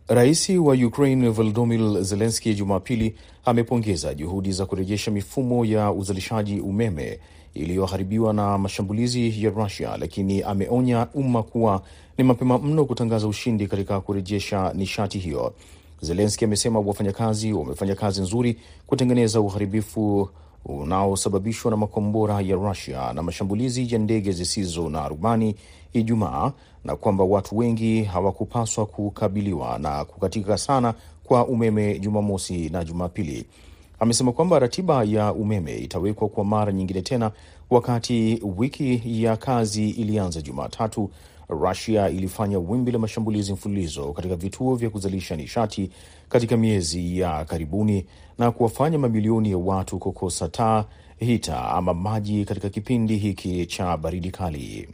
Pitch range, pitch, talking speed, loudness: 95-115 Hz, 105 Hz, 125 wpm, -23 LUFS